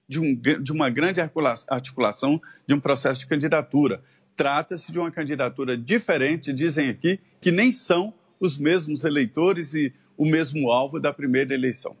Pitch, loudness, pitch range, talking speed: 155 Hz, -23 LUFS, 140-175 Hz, 155 wpm